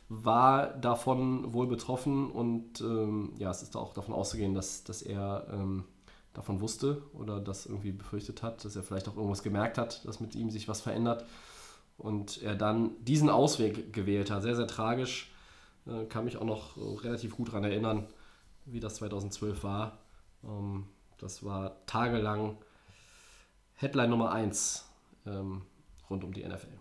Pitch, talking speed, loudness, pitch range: 110 Hz, 160 wpm, -34 LUFS, 100-115 Hz